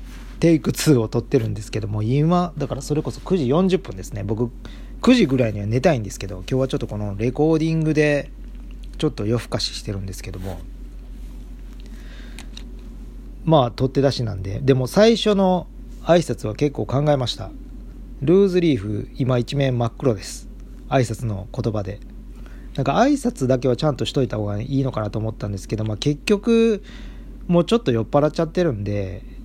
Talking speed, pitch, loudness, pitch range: 355 characters per minute, 130 Hz, -21 LUFS, 110-155 Hz